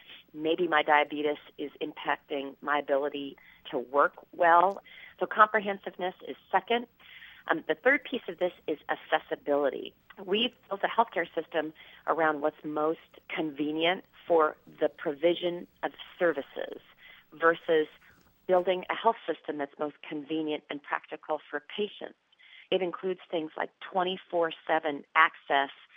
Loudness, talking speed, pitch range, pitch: -30 LUFS, 125 wpm, 155-190 Hz, 165 Hz